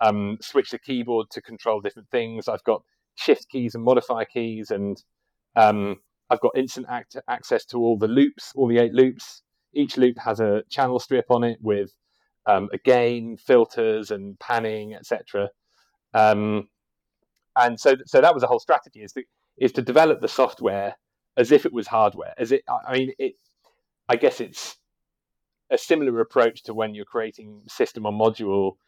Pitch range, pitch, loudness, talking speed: 105-130 Hz, 115 Hz, -22 LUFS, 175 wpm